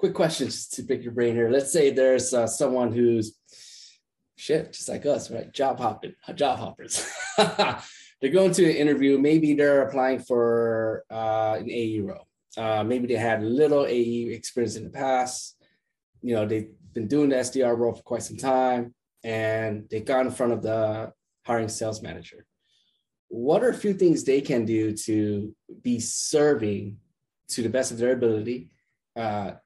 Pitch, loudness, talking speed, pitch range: 120 Hz, -25 LUFS, 170 wpm, 110-130 Hz